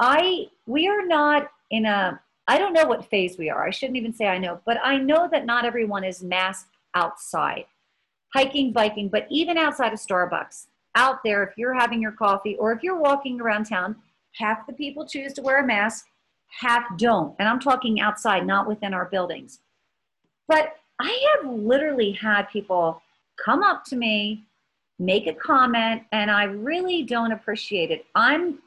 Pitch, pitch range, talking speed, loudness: 230 Hz, 205-285 Hz, 180 wpm, -23 LUFS